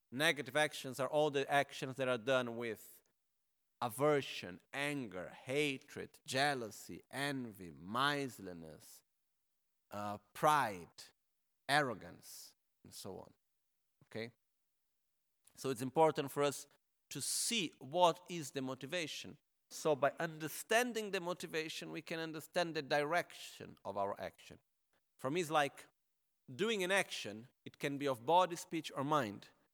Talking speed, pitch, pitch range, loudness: 125 wpm, 145 Hz, 130-160 Hz, -38 LUFS